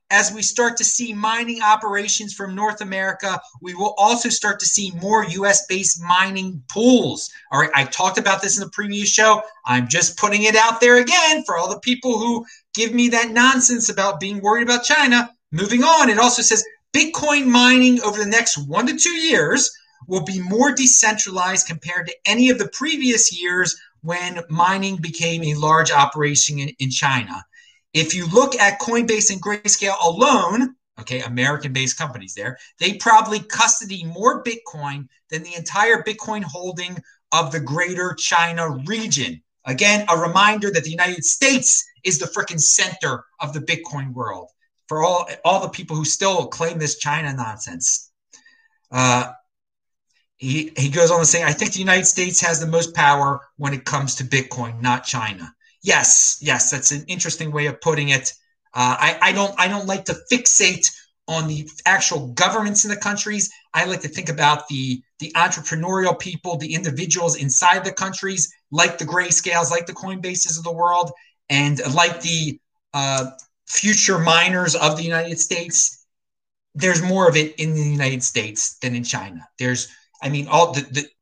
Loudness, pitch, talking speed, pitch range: -17 LUFS, 180 Hz, 175 wpm, 155-215 Hz